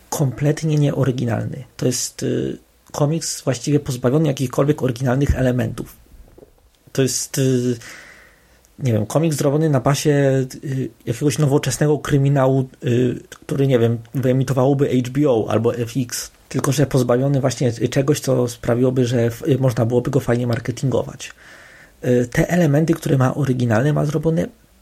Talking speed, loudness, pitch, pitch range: 135 wpm, -19 LUFS, 130 Hz, 125-145 Hz